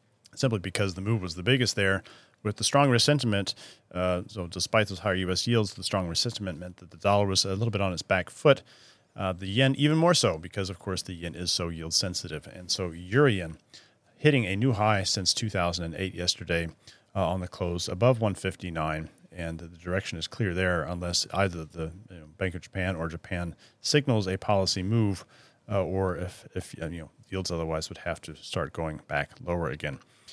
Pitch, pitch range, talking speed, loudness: 95 Hz, 85-105 Hz, 200 wpm, -28 LUFS